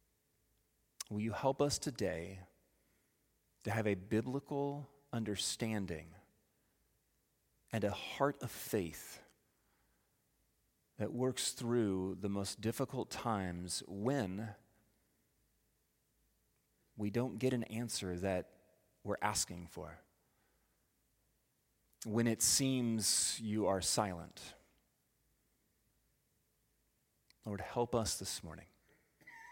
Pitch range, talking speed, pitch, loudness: 95-125 Hz, 85 wpm, 110 Hz, -38 LUFS